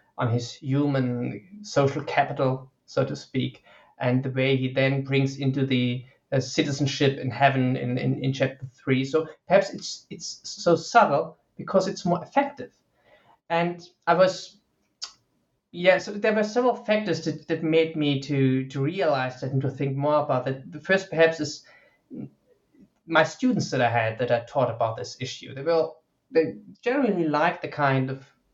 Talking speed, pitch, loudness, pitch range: 170 wpm, 145 Hz, -25 LUFS, 130-170 Hz